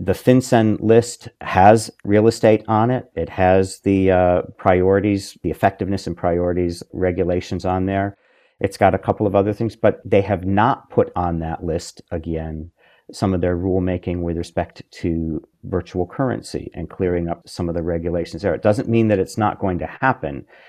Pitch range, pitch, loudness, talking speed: 85-105 Hz, 95 Hz, -19 LUFS, 180 wpm